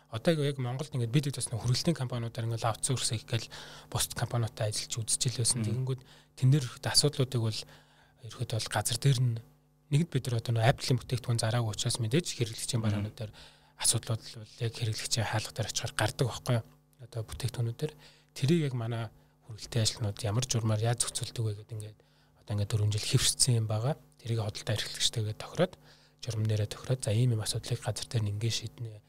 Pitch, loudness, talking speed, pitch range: 120 Hz, -31 LUFS, 165 wpm, 110-130 Hz